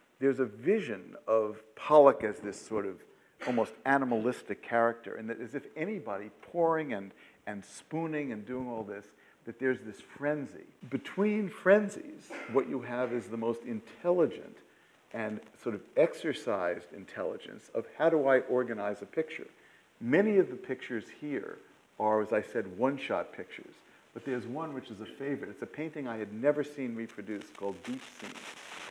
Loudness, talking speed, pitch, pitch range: -32 LUFS, 165 wpm, 125 Hz, 110-150 Hz